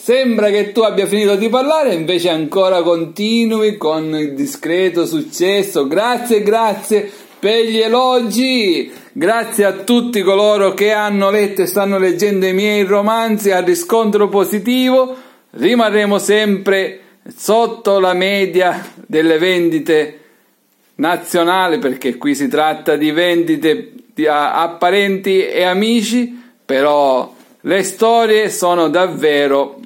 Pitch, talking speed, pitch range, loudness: 200 Hz, 115 wpm, 175-225 Hz, -14 LUFS